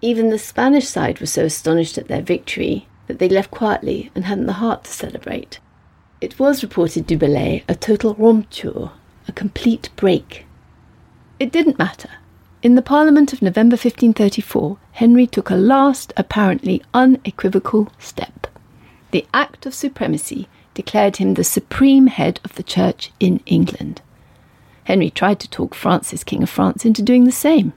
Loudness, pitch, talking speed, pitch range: -16 LUFS, 225 Hz, 160 wpm, 195-255 Hz